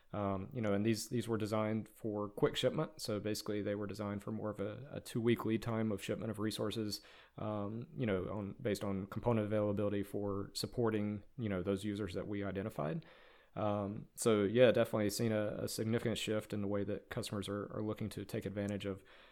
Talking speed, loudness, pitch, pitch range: 210 wpm, -38 LUFS, 105 Hz, 100-110 Hz